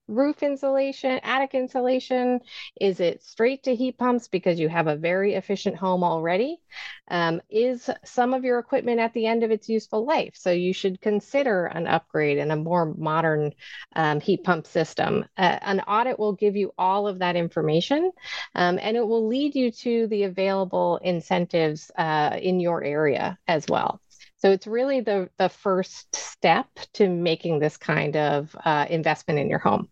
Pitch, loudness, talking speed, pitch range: 195 Hz, -24 LUFS, 175 wpm, 170-245 Hz